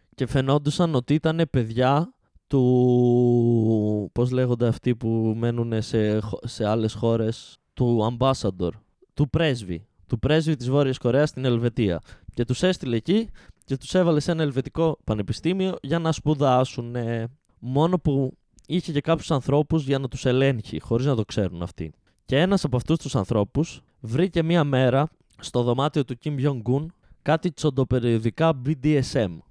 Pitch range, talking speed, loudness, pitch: 115-150 Hz, 145 wpm, -24 LUFS, 130 Hz